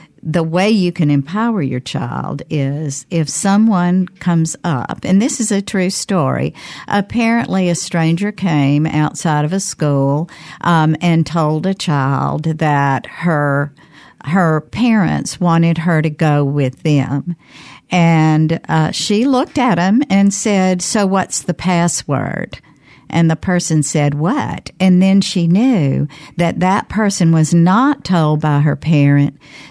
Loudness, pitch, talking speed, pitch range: -15 LUFS, 165 Hz, 145 wpm, 150-190 Hz